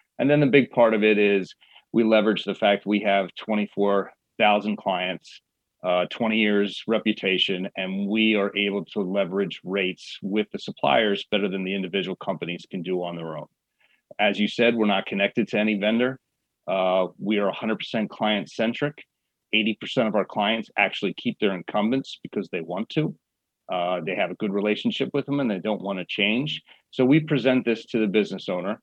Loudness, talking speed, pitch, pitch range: -24 LUFS, 185 wpm, 105 Hz, 95-115 Hz